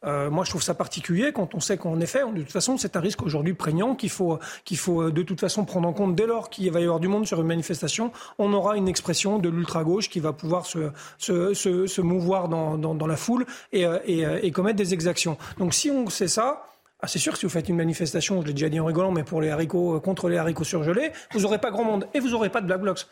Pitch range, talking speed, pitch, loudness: 165-200 Hz, 275 wpm, 180 Hz, -25 LUFS